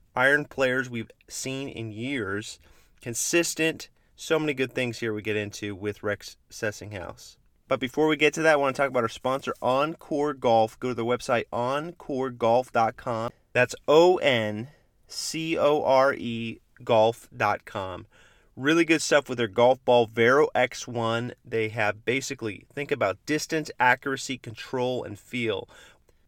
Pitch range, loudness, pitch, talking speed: 115-140 Hz, -25 LUFS, 125 Hz, 150 wpm